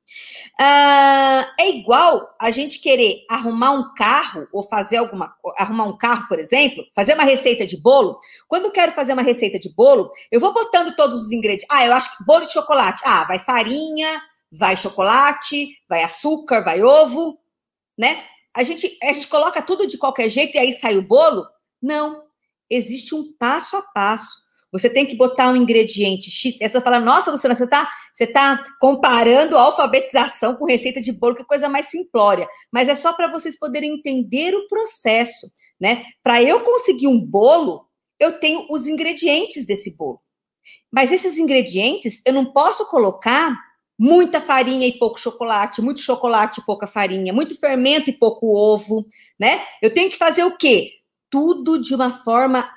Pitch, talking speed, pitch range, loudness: 270 Hz, 175 wpm, 235-315 Hz, -16 LUFS